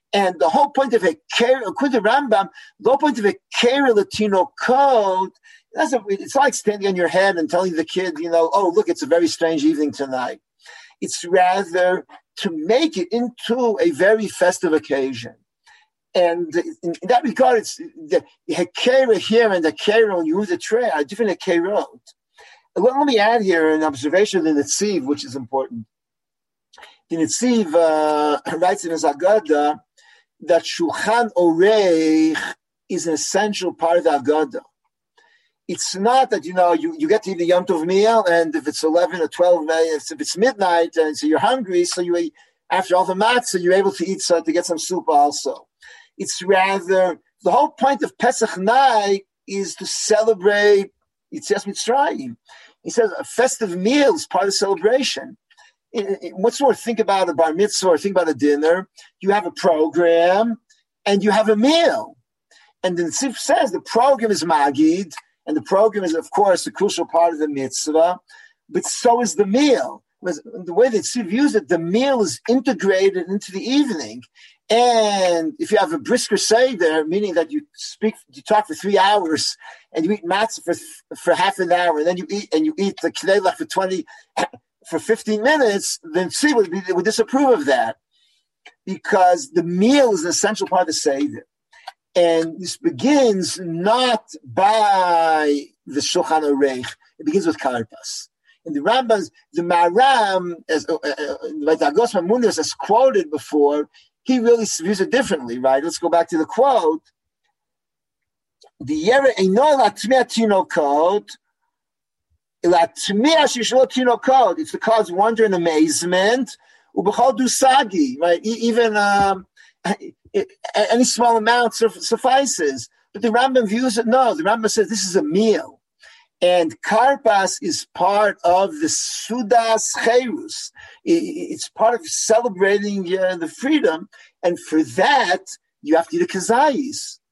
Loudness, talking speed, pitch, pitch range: -18 LUFS, 165 wpm, 200 Hz, 170-250 Hz